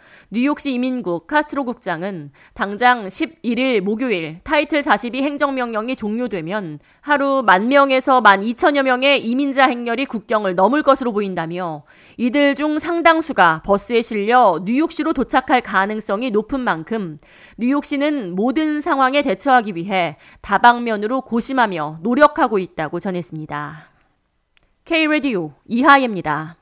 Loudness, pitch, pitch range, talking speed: -17 LUFS, 240 Hz, 190-275 Hz, 305 characters per minute